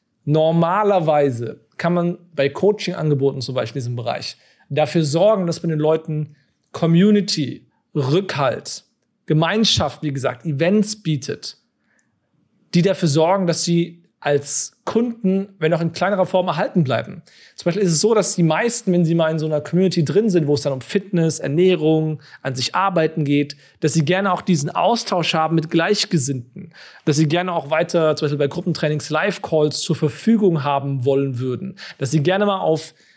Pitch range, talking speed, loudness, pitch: 150-185 Hz, 170 wpm, -19 LUFS, 165 Hz